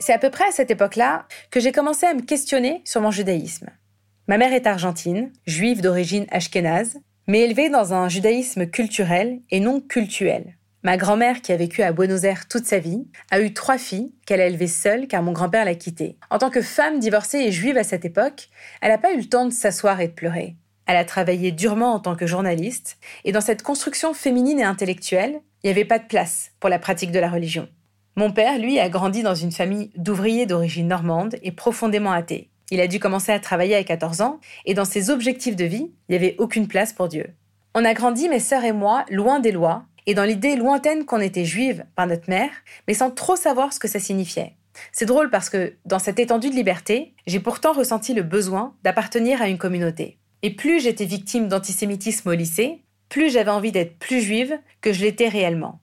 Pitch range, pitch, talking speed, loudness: 185-245 Hz, 210 Hz, 220 wpm, -21 LUFS